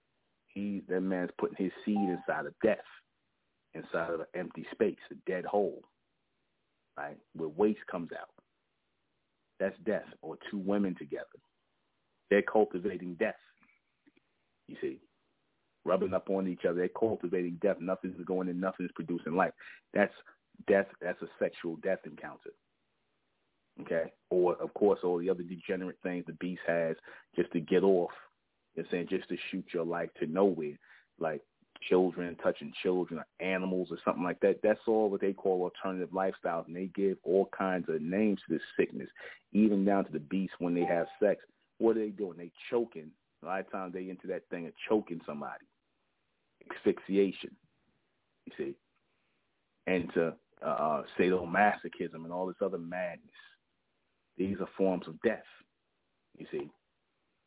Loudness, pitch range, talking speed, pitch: -33 LUFS, 85-95 Hz, 160 wpm, 90 Hz